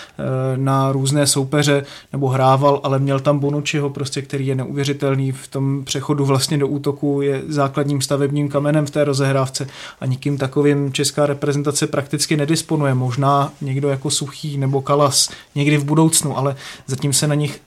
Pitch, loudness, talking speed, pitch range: 140 Hz, -18 LUFS, 160 wpm, 135-145 Hz